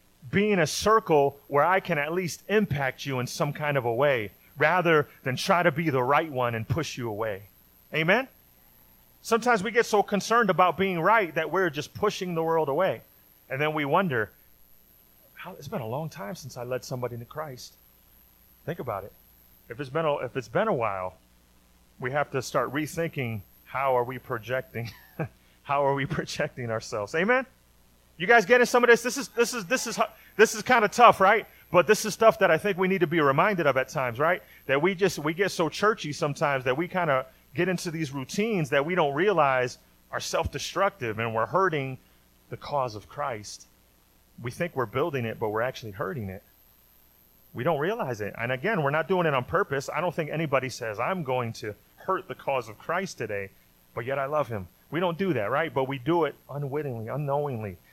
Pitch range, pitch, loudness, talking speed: 120-180 Hz, 145 Hz, -26 LUFS, 210 wpm